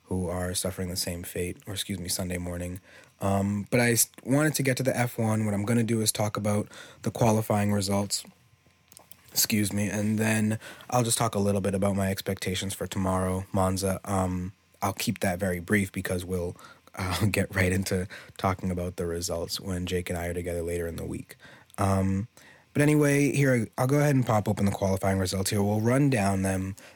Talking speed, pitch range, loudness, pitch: 205 wpm, 95-110 Hz, -27 LUFS, 100 Hz